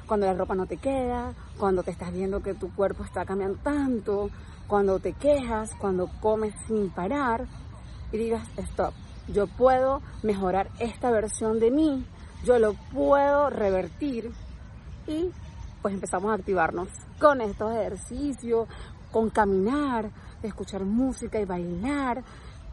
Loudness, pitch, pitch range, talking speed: -27 LUFS, 220 Hz, 195-255 Hz, 135 wpm